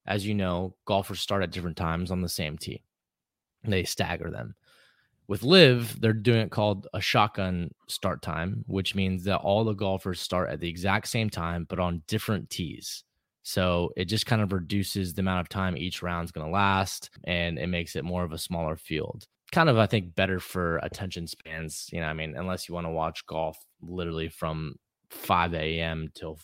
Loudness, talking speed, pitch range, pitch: -28 LUFS, 200 wpm, 85-100 Hz, 90 Hz